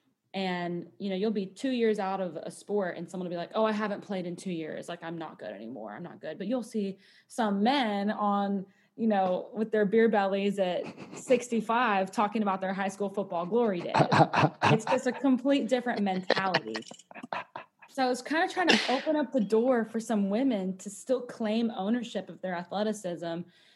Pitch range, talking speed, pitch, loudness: 190-230 Hz, 200 wpm, 205 Hz, -29 LUFS